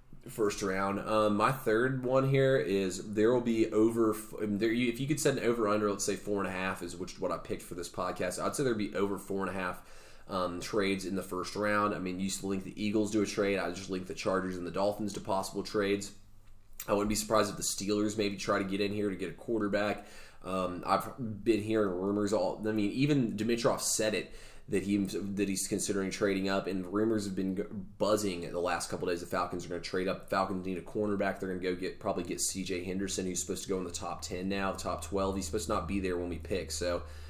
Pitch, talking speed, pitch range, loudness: 100 Hz, 255 wpm, 95-105 Hz, -32 LUFS